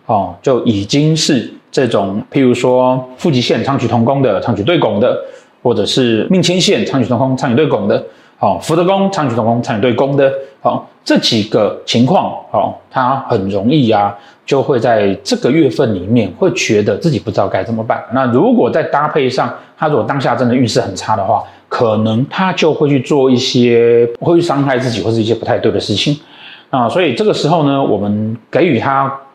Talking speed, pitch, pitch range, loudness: 290 characters per minute, 130 Hz, 115-150 Hz, -13 LUFS